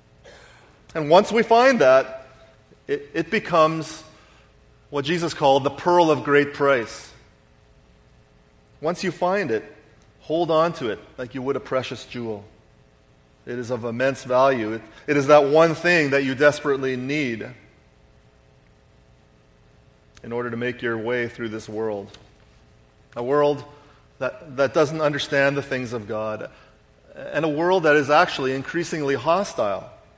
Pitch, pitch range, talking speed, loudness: 135 Hz, 110-155 Hz, 145 wpm, -21 LUFS